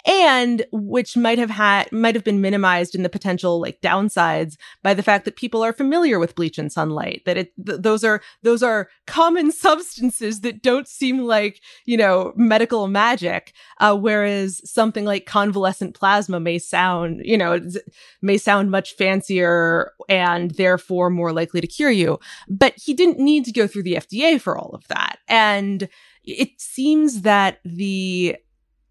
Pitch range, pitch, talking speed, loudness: 185-235 Hz, 205 Hz, 170 wpm, -19 LUFS